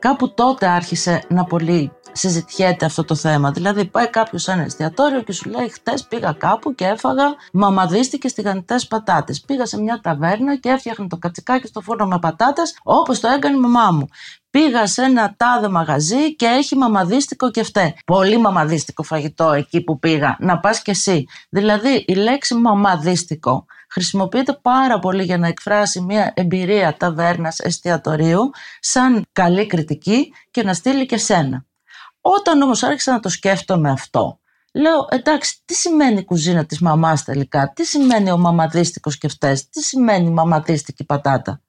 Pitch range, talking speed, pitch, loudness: 165-245 Hz, 160 wpm, 195 Hz, -17 LUFS